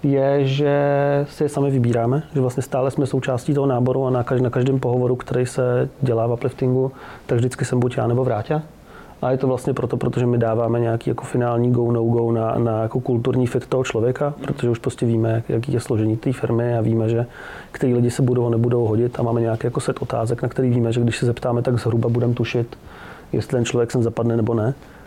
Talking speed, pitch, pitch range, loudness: 225 wpm, 125 Hz, 115-130 Hz, -20 LUFS